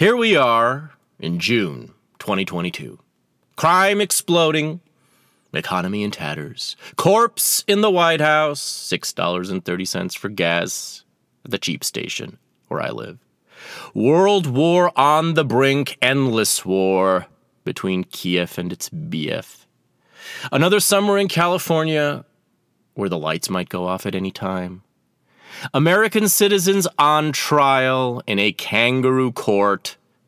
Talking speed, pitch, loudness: 115 wpm, 135 Hz, -19 LUFS